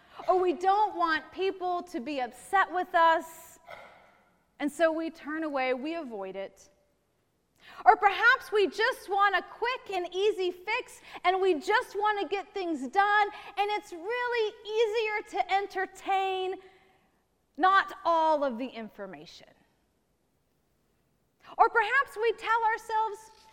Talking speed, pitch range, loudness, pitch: 135 wpm, 330-420 Hz, -28 LUFS, 375 Hz